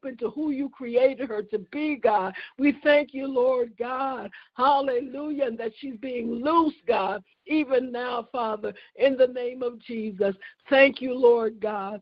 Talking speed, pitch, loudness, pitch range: 160 wpm, 255 Hz, -25 LUFS, 235-275 Hz